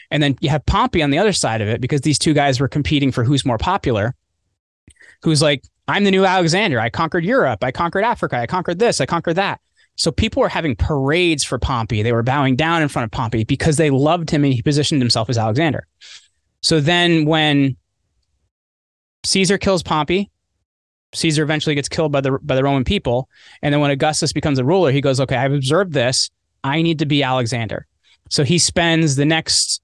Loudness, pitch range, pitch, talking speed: -17 LUFS, 125-160 Hz, 145 Hz, 205 wpm